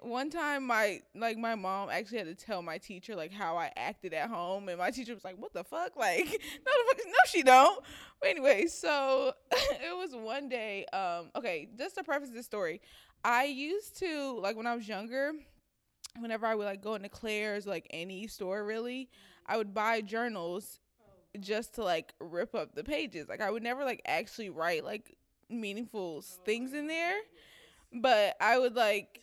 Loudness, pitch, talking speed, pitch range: -33 LUFS, 230 Hz, 195 wpm, 200-275 Hz